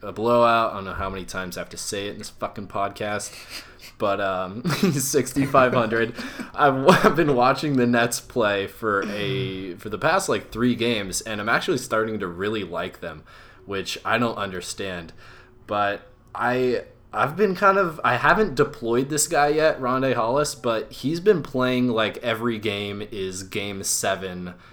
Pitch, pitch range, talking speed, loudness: 120 Hz, 100-135 Hz, 170 wpm, -23 LUFS